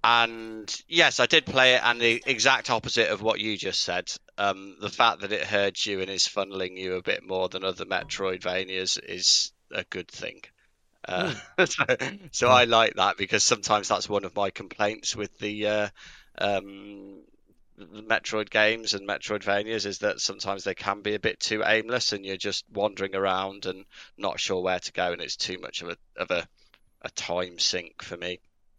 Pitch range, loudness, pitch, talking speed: 95-110 Hz, -25 LUFS, 100 Hz, 190 wpm